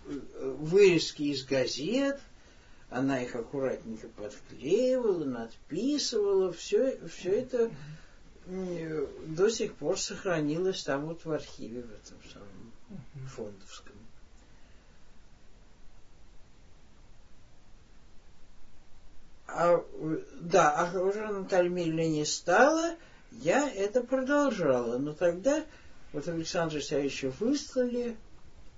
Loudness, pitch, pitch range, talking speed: -30 LUFS, 170 Hz, 135-225 Hz, 80 wpm